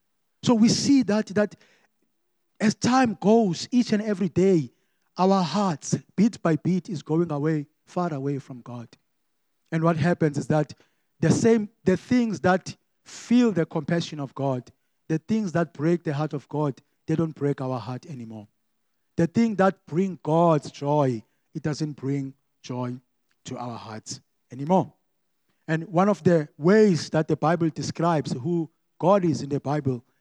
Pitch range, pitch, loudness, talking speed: 145-190 Hz, 165 Hz, -24 LUFS, 165 wpm